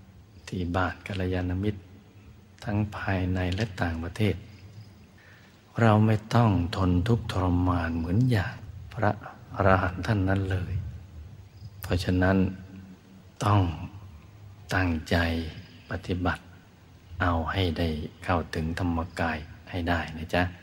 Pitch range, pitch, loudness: 90-105 Hz, 95 Hz, -28 LUFS